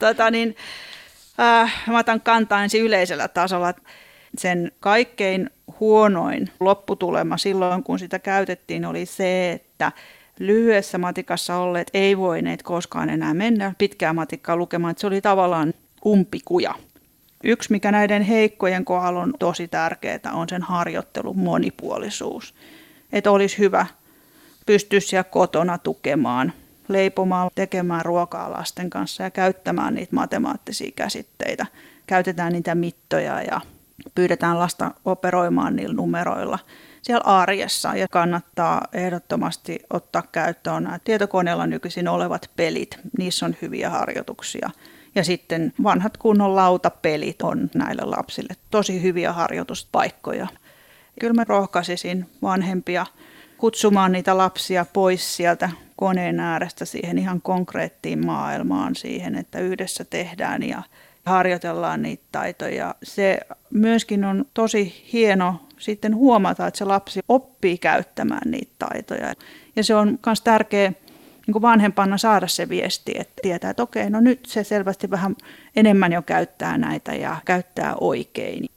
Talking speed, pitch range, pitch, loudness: 125 wpm, 180-220 Hz, 195 Hz, -21 LUFS